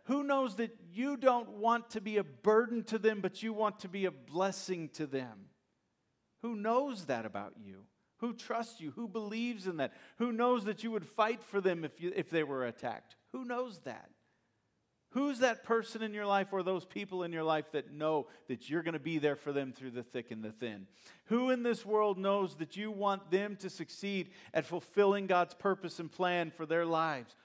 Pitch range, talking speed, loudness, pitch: 155-225 Hz, 215 wpm, -35 LUFS, 190 Hz